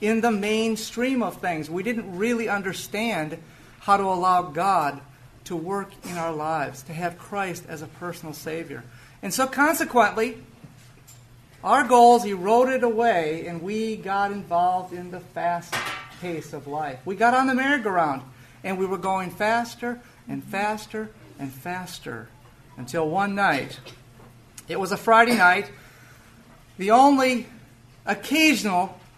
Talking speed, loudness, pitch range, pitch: 140 wpm, -23 LUFS, 140-220 Hz, 180 Hz